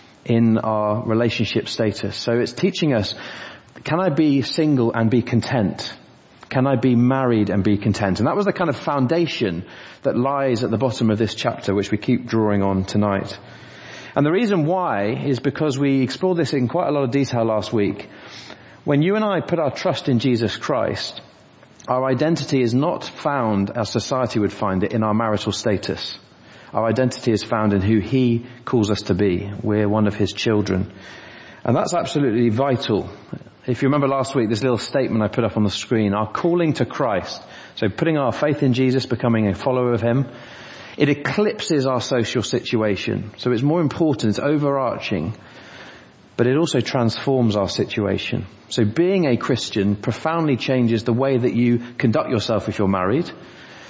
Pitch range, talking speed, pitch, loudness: 110-135 Hz, 185 wpm, 120 Hz, -20 LUFS